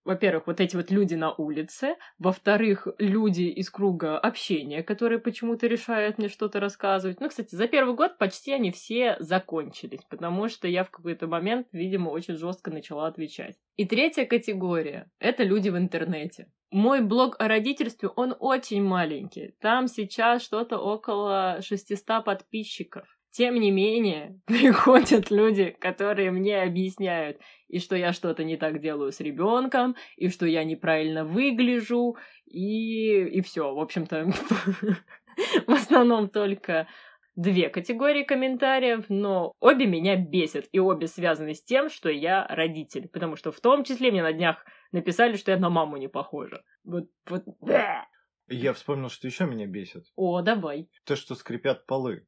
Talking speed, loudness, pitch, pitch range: 150 wpm, -26 LUFS, 195 Hz, 170-230 Hz